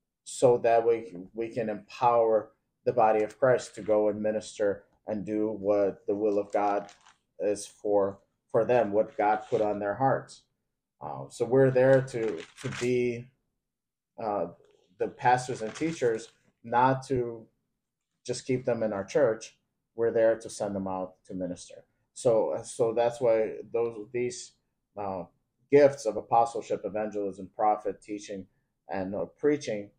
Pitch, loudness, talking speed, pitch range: 110 Hz, -28 LUFS, 150 wpm, 105-125 Hz